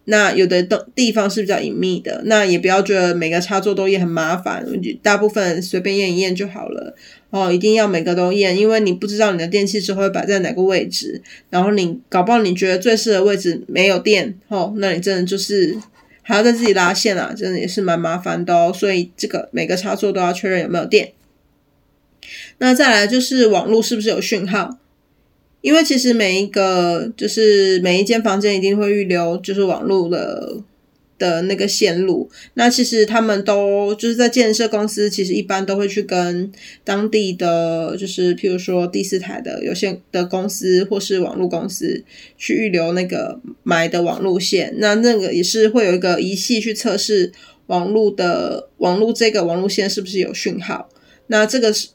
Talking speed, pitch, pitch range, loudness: 295 characters per minute, 200 Hz, 180-215 Hz, -17 LUFS